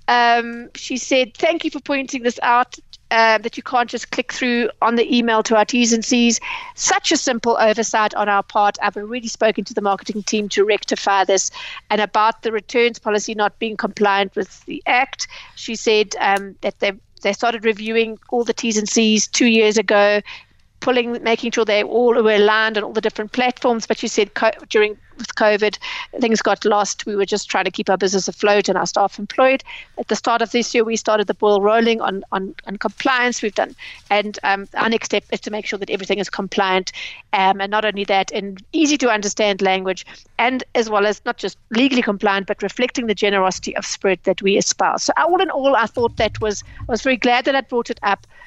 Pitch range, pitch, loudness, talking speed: 205-240 Hz, 220 Hz, -18 LUFS, 220 wpm